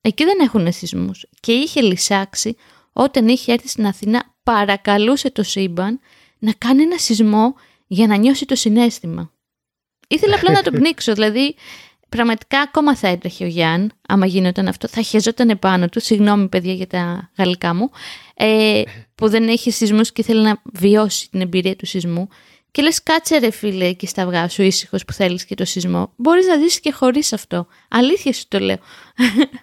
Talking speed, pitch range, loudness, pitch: 175 wpm, 190-250 Hz, -16 LUFS, 220 Hz